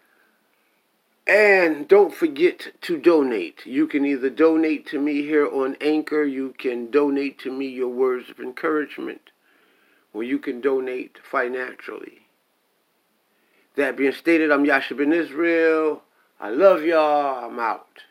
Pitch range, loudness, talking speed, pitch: 135-175 Hz, -21 LUFS, 135 wpm, 150 Hz